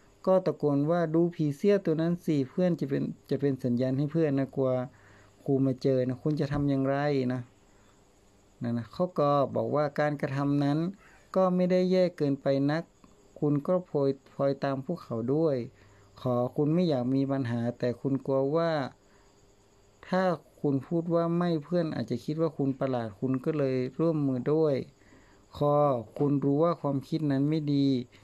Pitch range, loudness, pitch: 125-160 Hz, -29 LUFS, 140 Hz